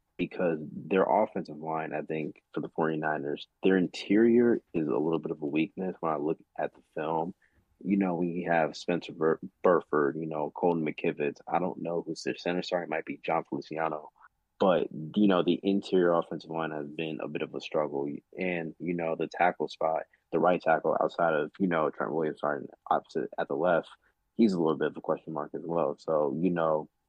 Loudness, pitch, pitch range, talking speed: -30 LUFS, 80 Hz, 75-90 Hz, 210 wpm